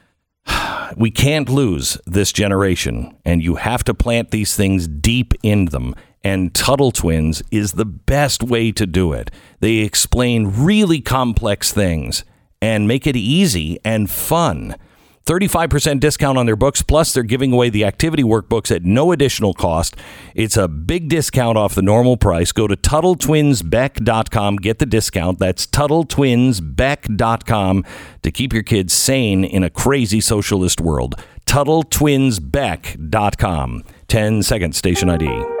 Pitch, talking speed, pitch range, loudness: 110 Hz, 140 wpm, 90-130 Hz, -16 LUFS